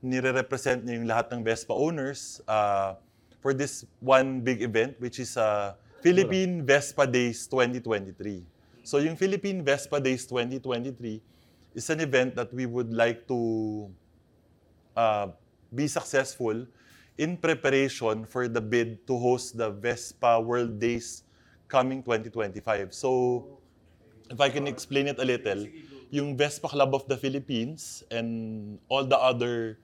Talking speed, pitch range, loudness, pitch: 135 wpm, 115-135 Hz, -28 LUFS, 125 Hz